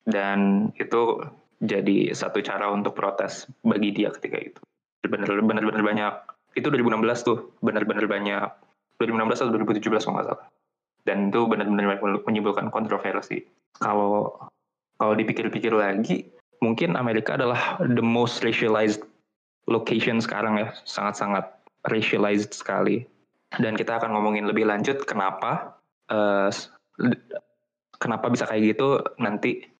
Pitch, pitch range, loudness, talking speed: 105 Hz, 100-115 Hz, -25 LUFS, 120 wpm